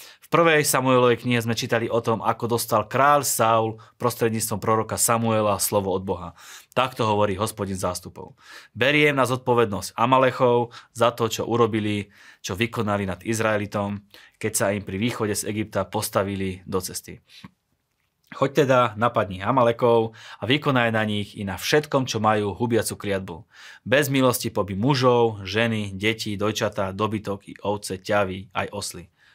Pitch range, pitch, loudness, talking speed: 100-120 Hz, 110 Hz, -23 LUFS, 145 wpm